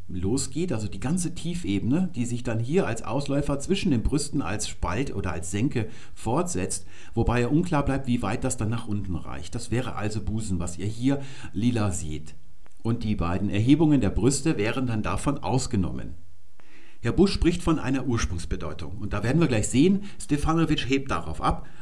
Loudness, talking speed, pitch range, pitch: -27 LUFS, 180 wpm, 95-140 Hz, 115 Hz